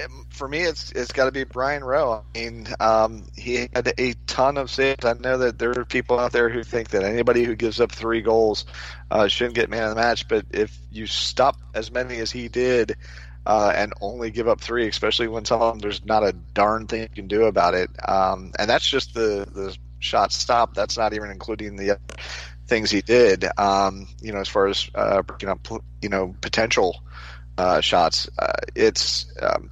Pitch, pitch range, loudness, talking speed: 110 Hz, 95-120 Hz, -22 LUFS, 215 wpm